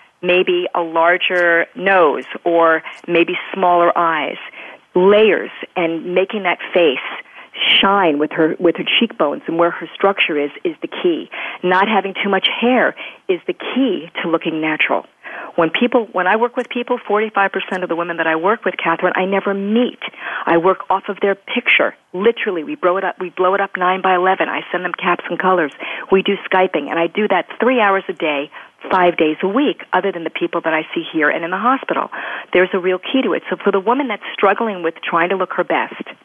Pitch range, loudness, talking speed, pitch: 170-210 Hz, -16 LUFS, 210 wpm, 185 Hz